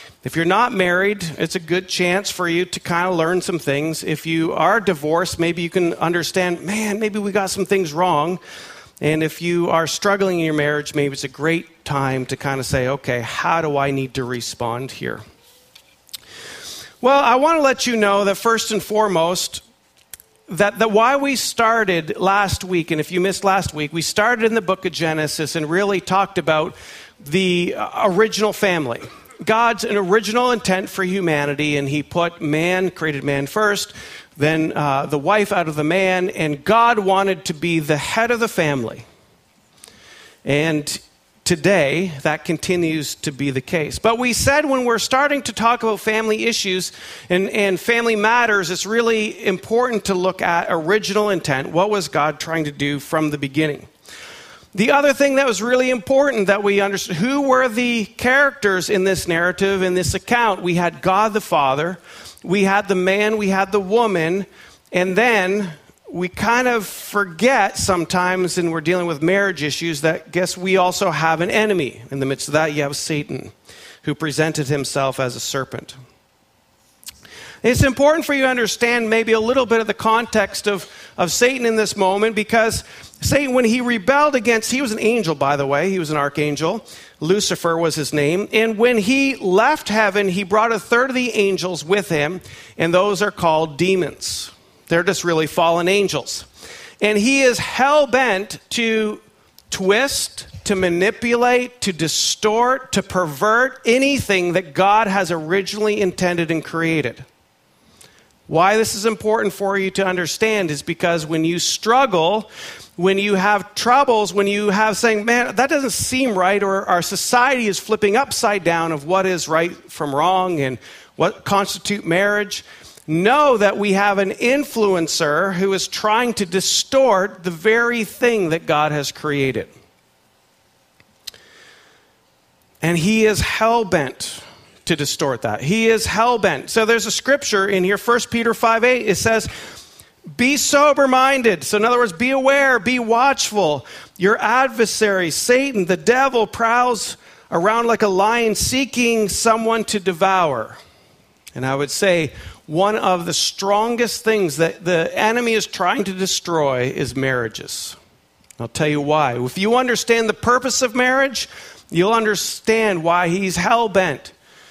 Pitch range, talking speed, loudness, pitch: 165-225 Hz, 165 wpm, -18 LUFS, 195 Hz